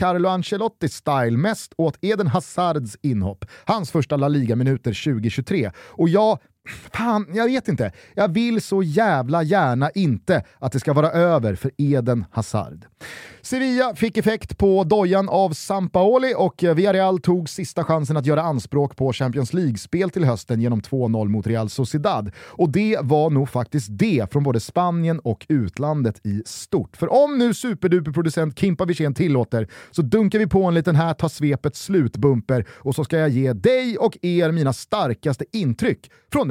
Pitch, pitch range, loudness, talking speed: 155 Hz, 130-190 Hz, -21 LUFS, 160 wpm